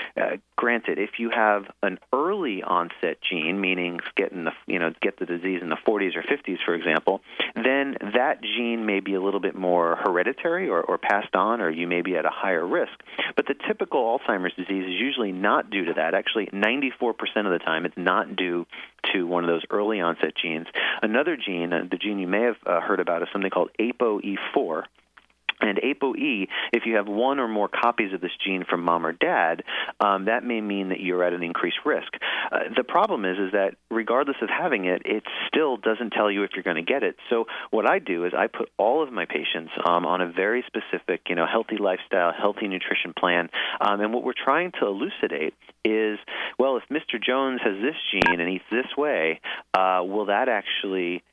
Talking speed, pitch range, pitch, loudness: 210 wpm, 85-105 Hz, 95 Hz, -25 LUFS